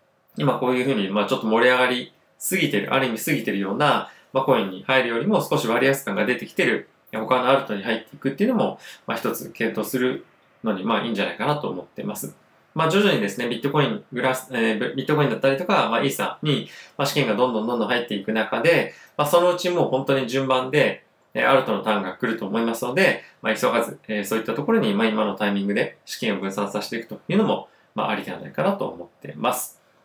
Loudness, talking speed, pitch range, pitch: -22 LUFS, 495 characters per minute, 110-135 Hz, 125 Hz